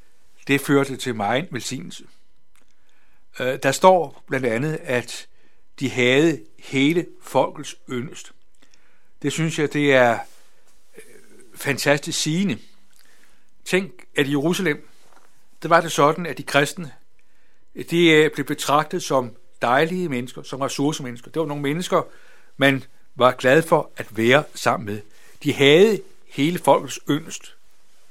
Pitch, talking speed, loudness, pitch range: 145 Hz, 125 wpm, -20 LUFS, 130-165 Hz